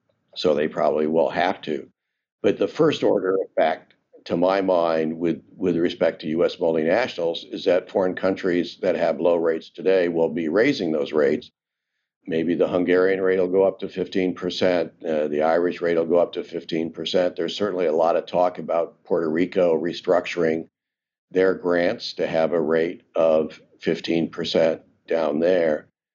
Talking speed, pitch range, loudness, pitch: 170 wpm, 80-90 Hz, -22 LUFS, 85 Hz